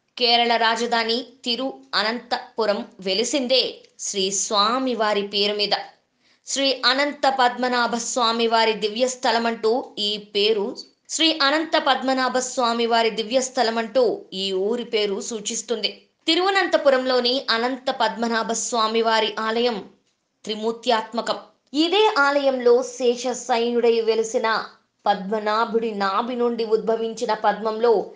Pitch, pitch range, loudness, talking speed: 235 Hz, 220-255 Hz, -21 LUFS, 100 wpm